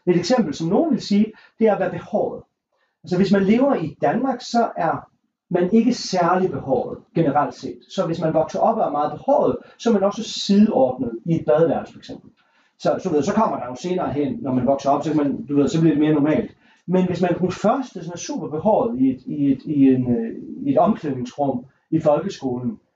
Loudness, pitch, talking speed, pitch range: -20 LUFS, 180 Hz, 215 wpm, 145-220 Hz